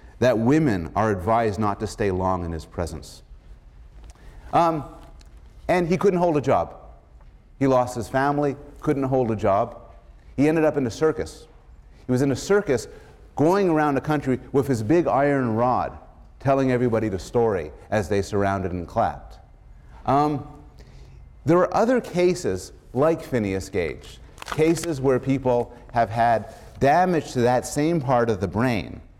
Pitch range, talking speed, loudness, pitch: 105-150 Hz, 155 wpm, -23 LUFS, 125 Hz